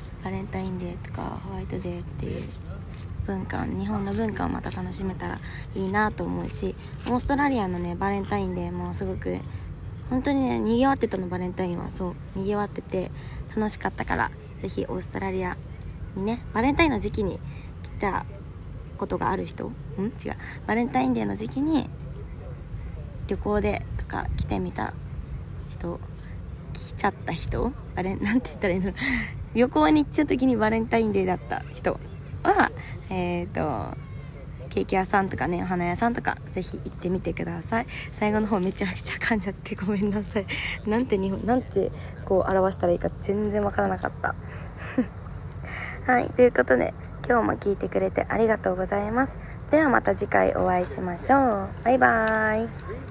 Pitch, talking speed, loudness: 180 Hz, 350 characters per minute, -26 LUFS